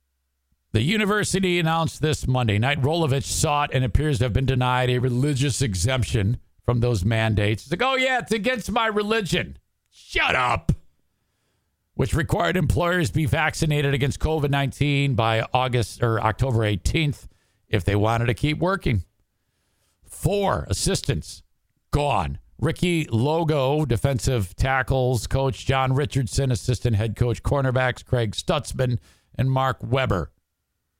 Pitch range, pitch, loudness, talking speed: 110-150 Hz, 130 Hz, -23 LUFS, 130 wpm